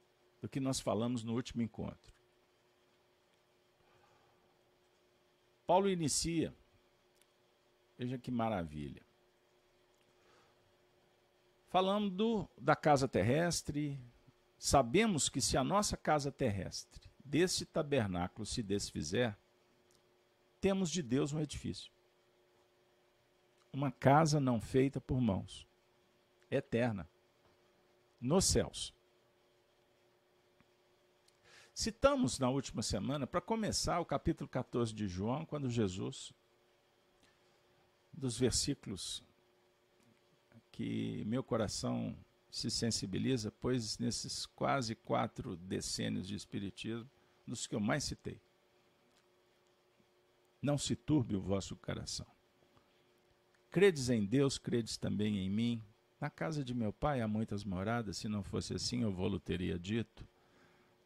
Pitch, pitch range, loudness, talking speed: 120 Hz, 110-135 Hz, -36 LUFS, 100 wpm